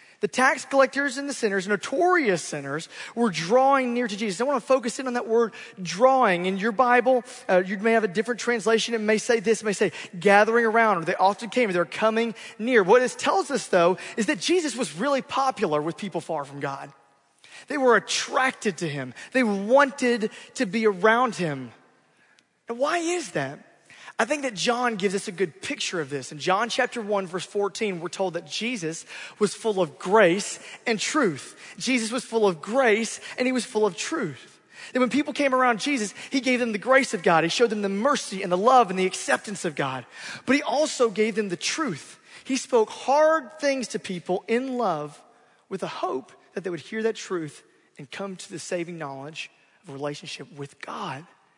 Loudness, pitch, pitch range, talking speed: -24 LUFS, 220 Hz, 185-255 Hz, 210 wpm